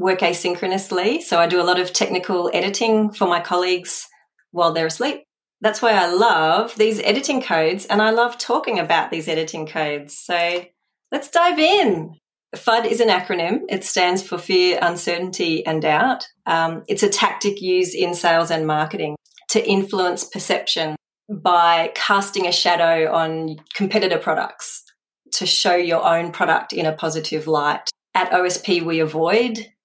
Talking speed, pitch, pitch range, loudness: 155 wpm, 180 Hz, 165-205 Hz, -19 LUFS